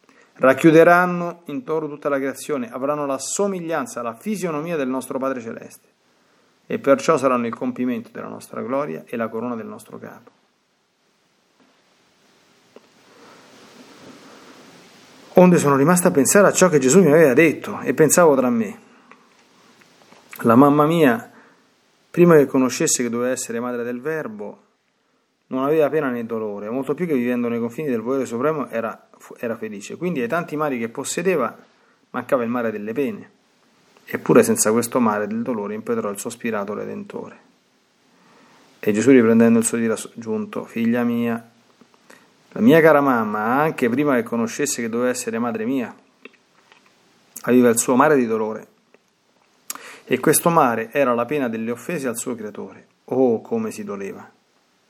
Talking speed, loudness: 150 wpm, -19 LUFS